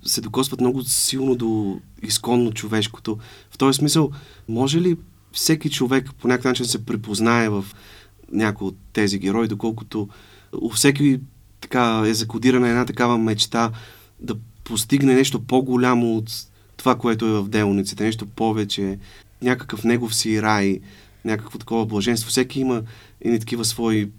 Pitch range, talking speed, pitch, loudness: 105-125 Hz, 140 wpm, 115 Hz, -21 LUFS